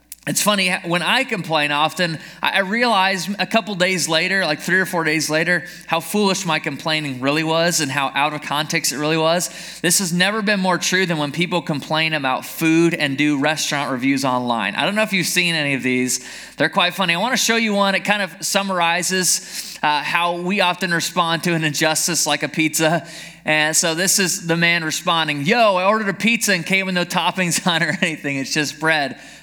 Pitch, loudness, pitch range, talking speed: 170 Hz, -18 LUFS, 155-185 Hz, 215 wpm